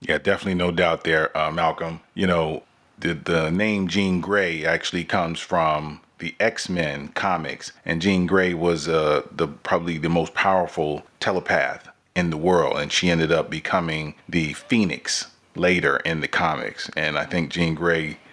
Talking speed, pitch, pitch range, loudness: 165 wpm, 85 Hz, 80-90 Hz, -22 LUFS